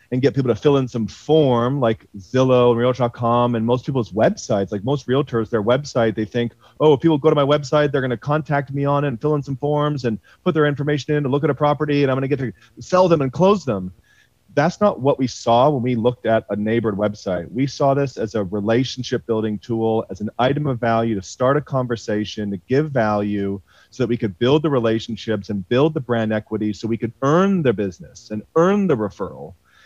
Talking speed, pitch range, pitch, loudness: 230 wpm, 110-145 Hz, 125 Hz, -20 LUFS